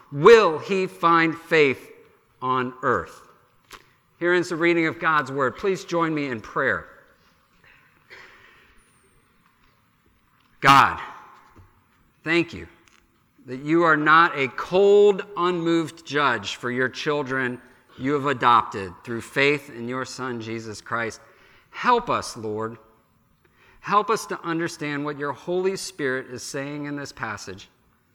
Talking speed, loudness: 125 wpm, -22 LUFS